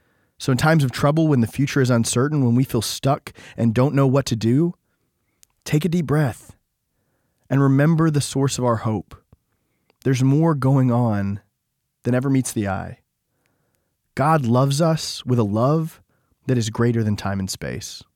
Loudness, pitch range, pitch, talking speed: -20 LUFS, 115-140 Hz, 130 Hz, 175 wpm